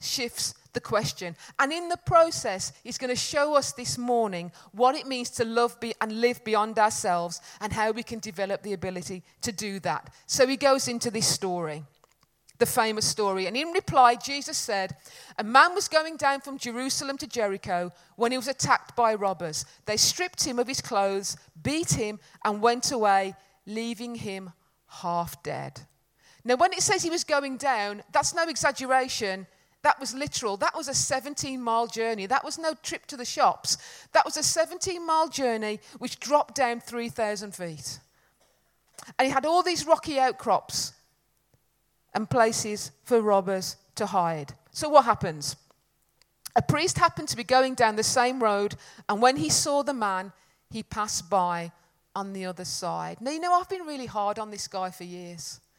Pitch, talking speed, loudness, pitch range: 225 Hz, 175 wpm, -26 LUFS, 185-270 Hz